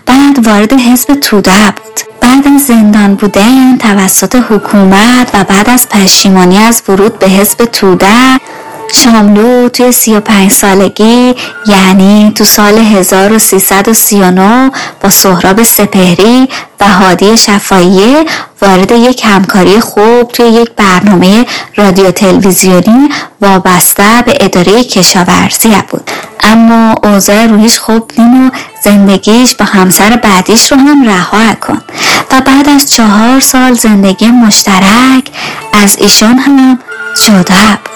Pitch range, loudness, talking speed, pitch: 195-245 Hz, -4 LUFS, 115 wpm, 215 Hz